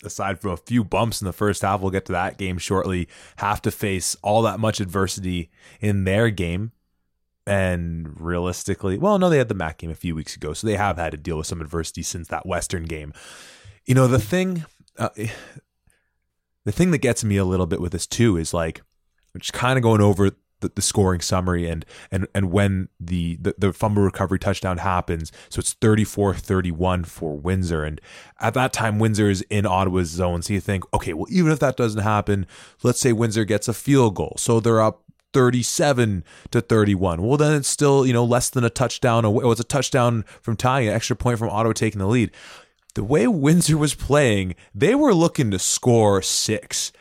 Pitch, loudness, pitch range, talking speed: 100 Hz, -21 LUFS, 90-115 Hz, 210 wpm